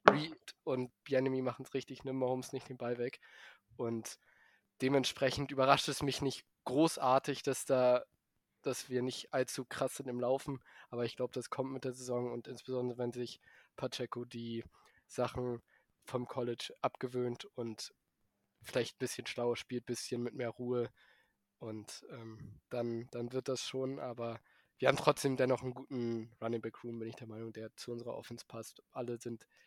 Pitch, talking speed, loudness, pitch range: 125 Hz, 170 wpm, -38 LUFS, 120-130 Hz